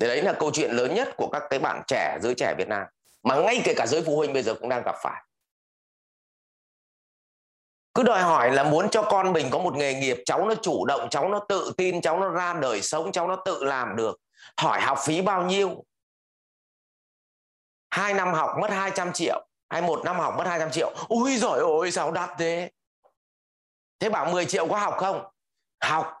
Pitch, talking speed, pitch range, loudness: 180 Hz, 210 wpm, 160-195 Hz, -25 LUFS